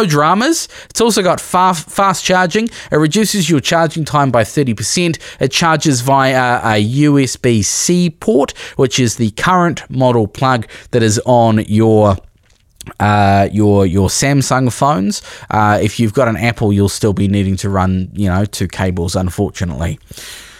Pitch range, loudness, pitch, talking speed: 105-150 Hz, -13 LUFS, 120 Hz, 155 wpm